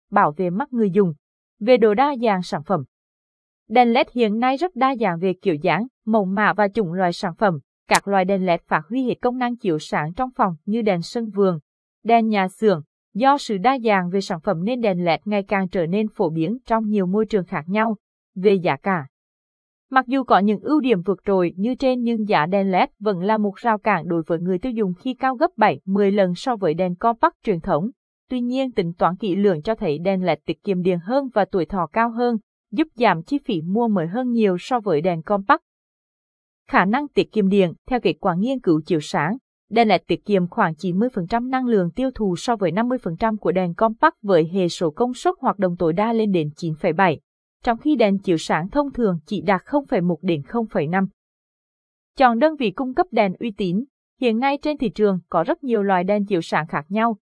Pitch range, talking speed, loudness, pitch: 185-235 Hz, 225 wpm, -21 LUFS, 210 Hz